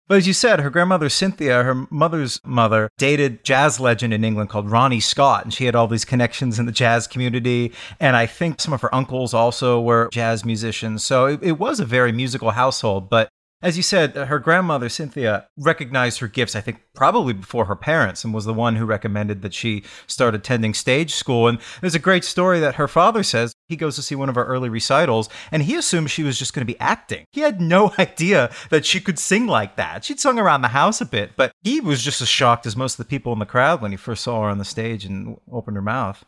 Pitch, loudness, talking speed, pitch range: 125 Hz, -19 LUFS, 240 wpm, 115-155 Hz